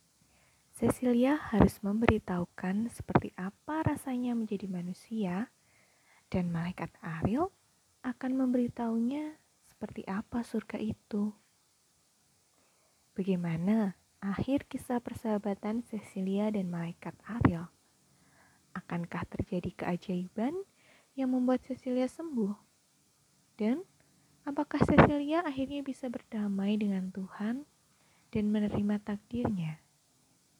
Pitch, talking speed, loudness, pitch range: 215 Hz, 85 wpm, -33 LUFS, 190-255 Hz